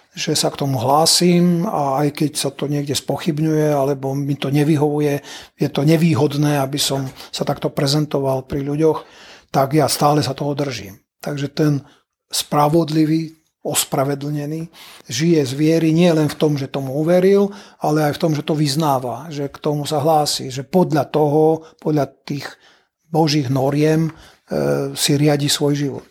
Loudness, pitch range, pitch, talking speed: -18 LUFS, 140-160 Hz, 150 Hz, 160 wpm